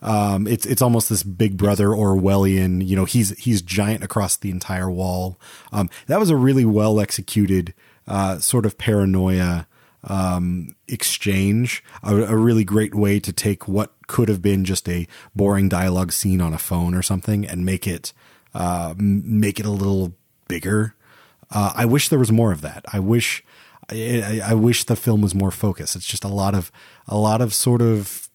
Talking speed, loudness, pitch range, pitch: 185 wpm, -20 LUFS, 95-110 Hz, 100 Hz